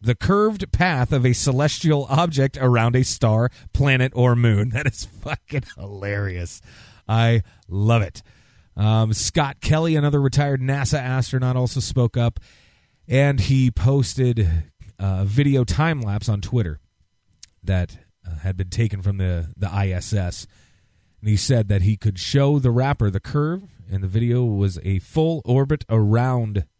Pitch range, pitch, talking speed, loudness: 100-135 Hz, 115 Hz, 150 wpm, -21 LUFS